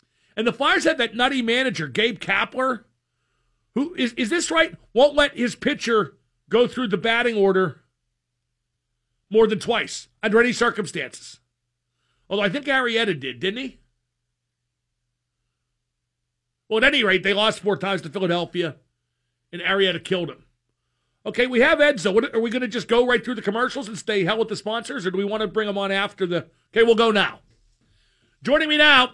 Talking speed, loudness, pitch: 180 wpm, -21 LUFS, 205 Hz